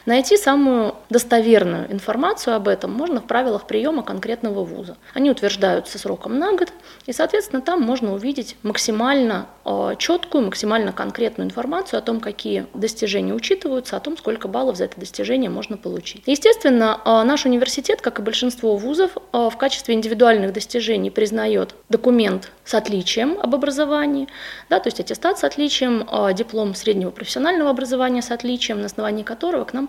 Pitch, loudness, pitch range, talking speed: 240 Hz, -20 LUFS, 220-275 Hz, 150 wpm